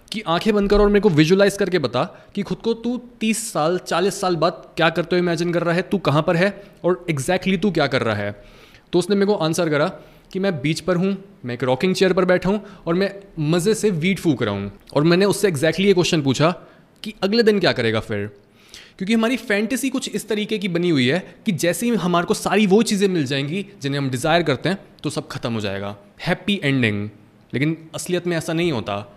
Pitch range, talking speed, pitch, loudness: 150-200 Hz, 235 wpm, 175 Hz, -20 LUFS